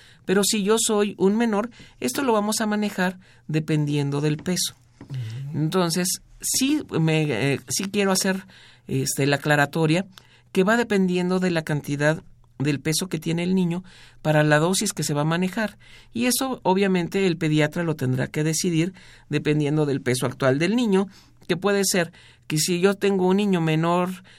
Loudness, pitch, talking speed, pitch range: -23 LUFS, 170 Hz, 170 wpm, 150-195 Hz